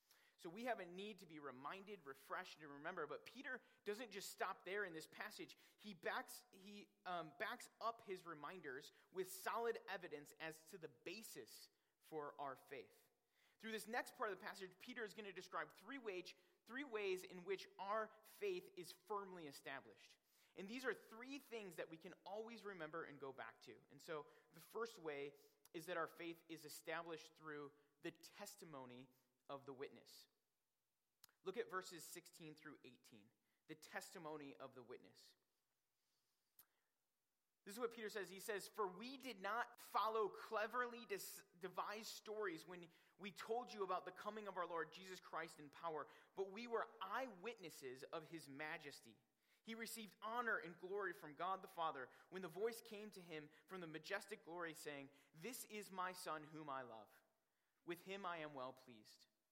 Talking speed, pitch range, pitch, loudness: 175 wpm, 160-220 Hz, 185 Hz, -52 LUFS